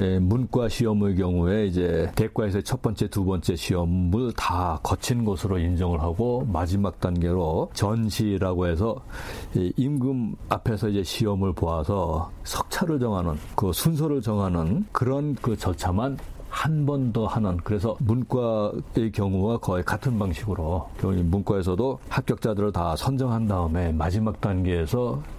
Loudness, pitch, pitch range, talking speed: -25 LUFS, 105 Hz, 90-120 Hz, 295 characters per minute